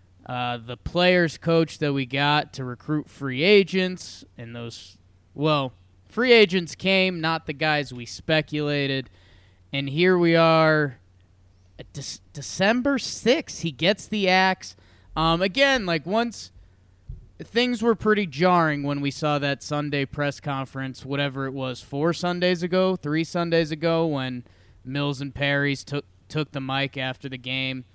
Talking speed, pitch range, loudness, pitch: 150 wpm, 130-170 Hz, -23 LUFS, 145 Hz